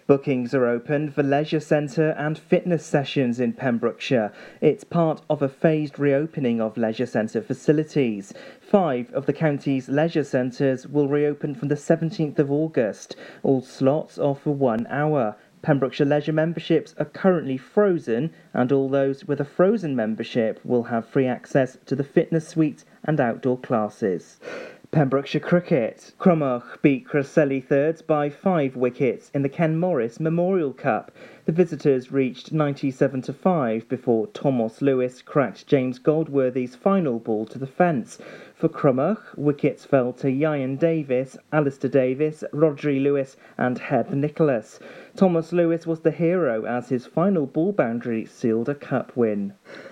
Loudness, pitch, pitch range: -23 LUFS, 145 Hz, 130-155 Hz